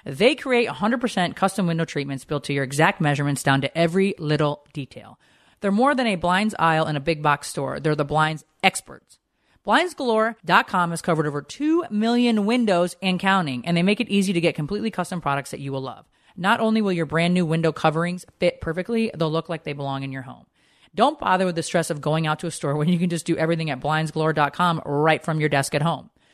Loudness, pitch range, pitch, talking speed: -22 LUFS, 150-195 Hz, 165 Hz, 220 wpm